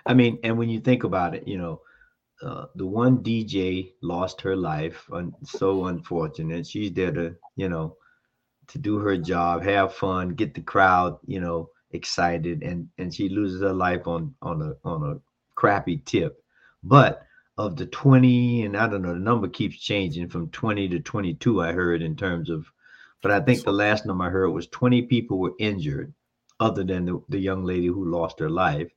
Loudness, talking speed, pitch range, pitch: -24 LUFS, 195 wpm, 85-115 Hz, 95 Hz